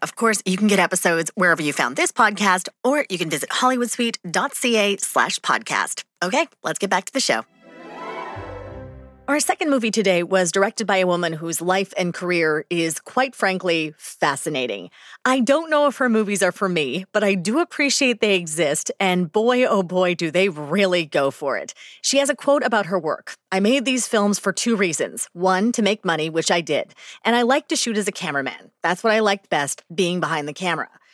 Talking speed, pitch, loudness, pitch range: 200 wpm, 195 Hz, -20 LUFS, 175-235 Hz